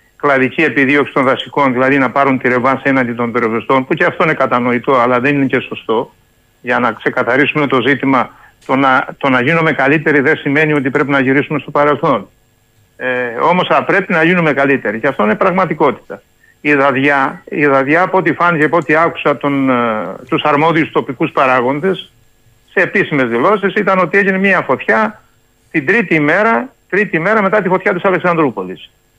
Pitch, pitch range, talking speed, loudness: 145 Hz, 130-165 Hz, 180 wpm, -13 LUFS